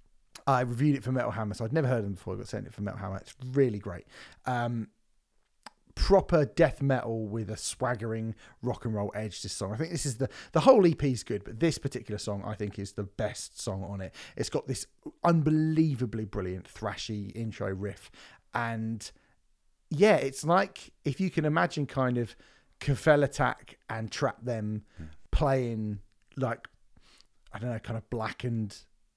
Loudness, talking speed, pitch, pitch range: -30 LUFS, 180 wpm, 115 Hz, 105-135 Hz